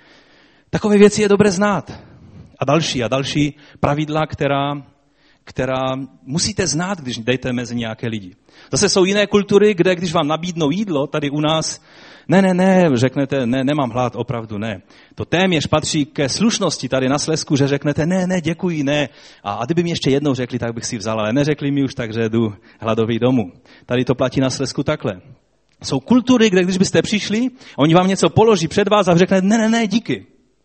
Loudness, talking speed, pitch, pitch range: -17 LUFS, 190 wpm, 145 Hz, 130-185 Hz